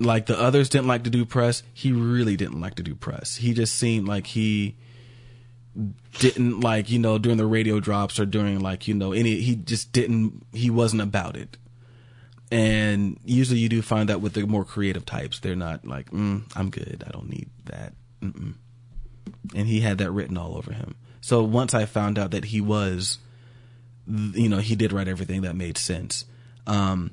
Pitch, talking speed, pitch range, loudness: 115 Hz, 195 wpm, 100-120 Hz, -24 LUFS